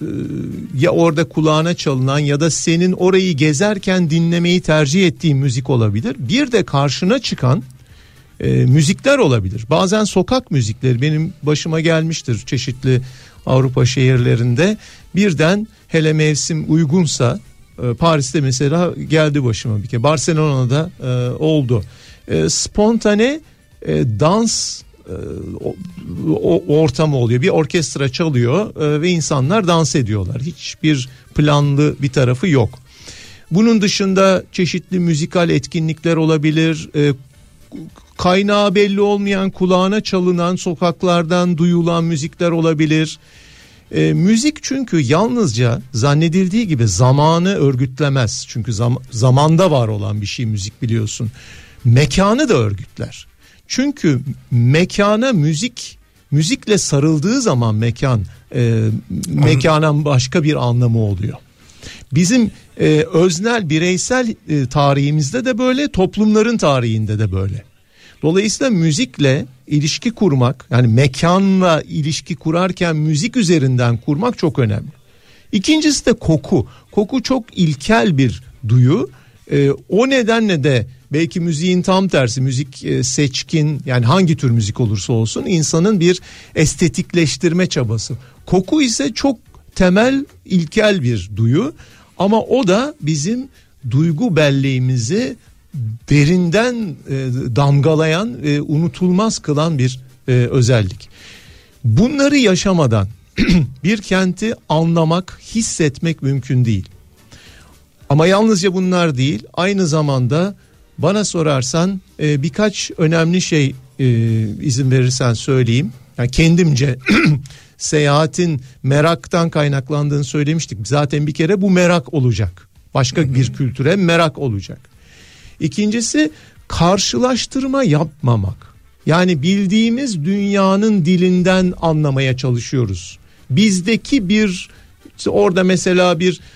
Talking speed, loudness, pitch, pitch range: 100 wpm, -15 LUFS, 155 Hz, 130-185 Hz